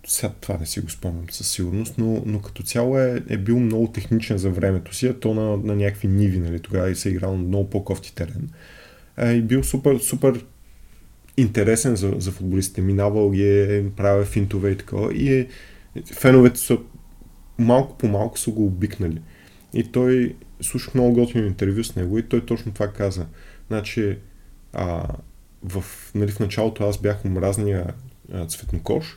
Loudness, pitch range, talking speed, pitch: -22 LUFS, 95-115 Hz, 175 wpm, 105 Hz